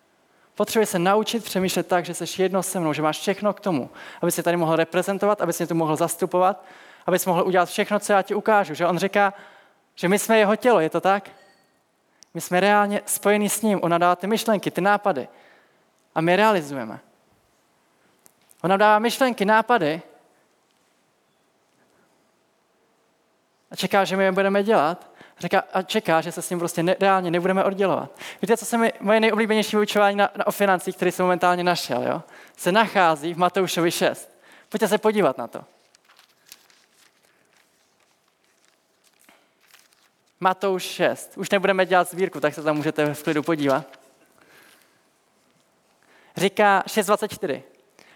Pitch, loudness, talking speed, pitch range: 190 Hz, -22 LUFS, 155 wpm, 175-205 Hz